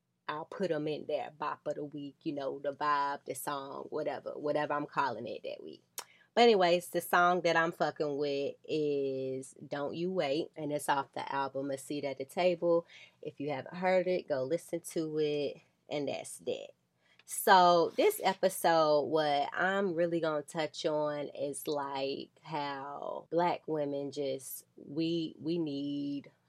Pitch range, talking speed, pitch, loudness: 145-175 Hz, 170 wpm, 150 Hz, -33 LUFS